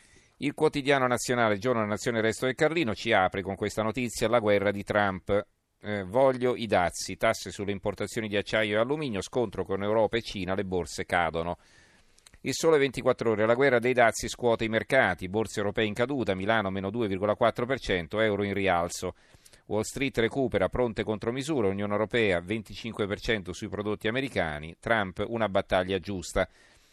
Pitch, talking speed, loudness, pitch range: 110 Hz, 165 wpm, -28 LUFS, 100-120 Hz